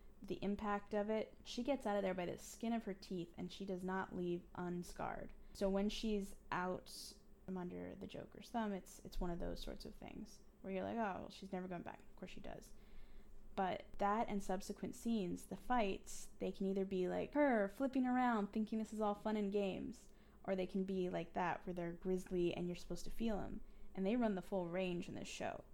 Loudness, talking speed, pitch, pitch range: -43 LUFS, 225 wpm, 195 Hz, 185-215 Hz